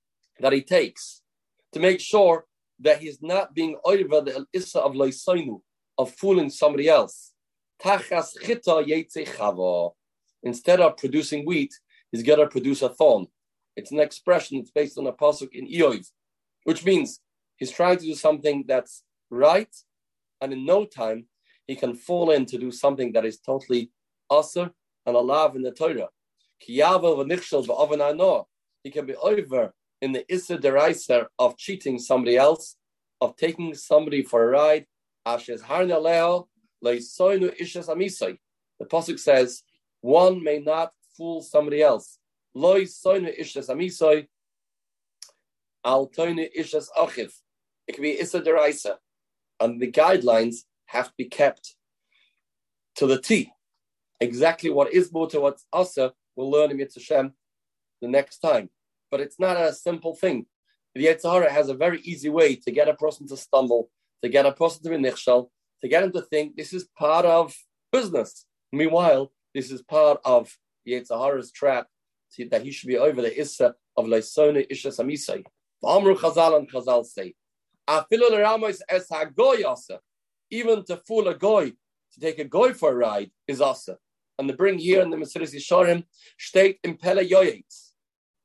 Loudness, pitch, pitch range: -23 LUFS, 155 Hz, 135-180 Hz